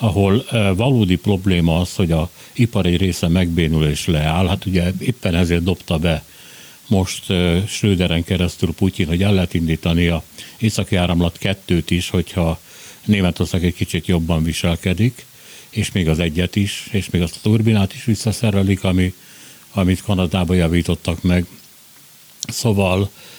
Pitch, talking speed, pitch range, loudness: 90 Hz, 140 wpm, 85-100 Hz, -18 LUFS